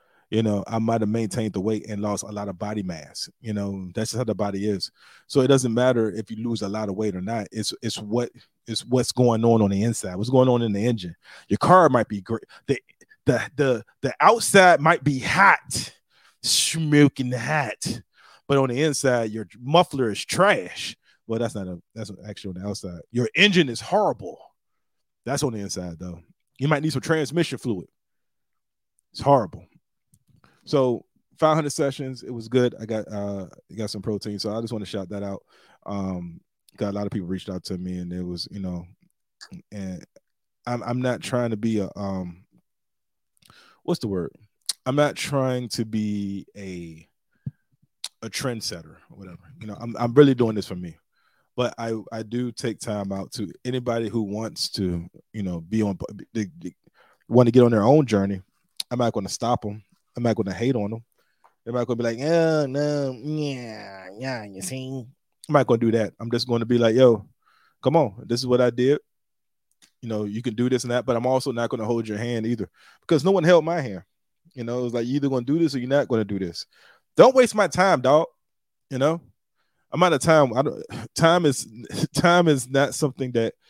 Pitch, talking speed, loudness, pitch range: 115 Hz, 210 wpm, -23 LUFS, 105-130 Hz